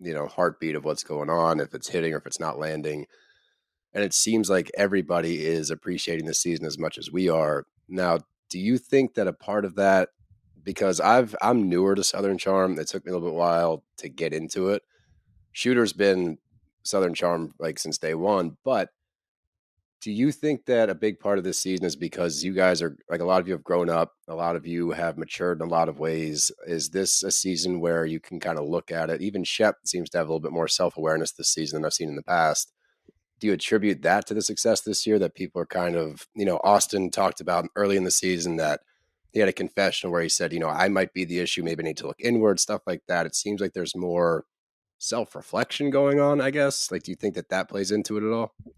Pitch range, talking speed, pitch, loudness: 85-100 Hz, 245 wpm, 90 Hz, -25 LUFS